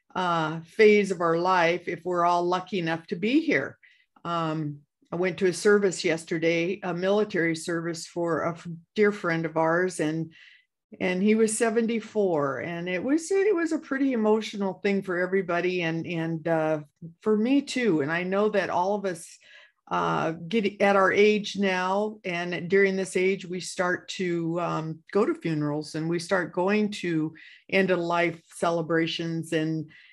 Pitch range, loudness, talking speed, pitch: 165-200 Hz, -26 LUFS, 170 wpm, 180 Hz